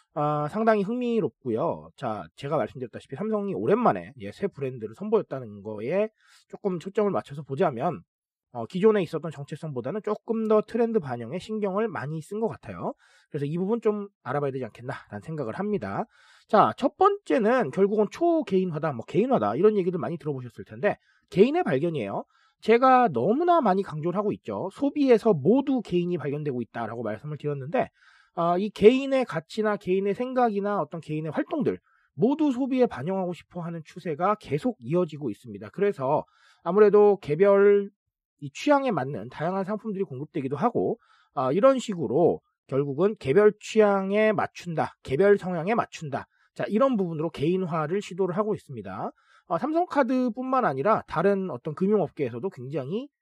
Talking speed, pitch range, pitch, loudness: 375 characters per minute, 150-220 Hz, 195 Hz, -26 LUFS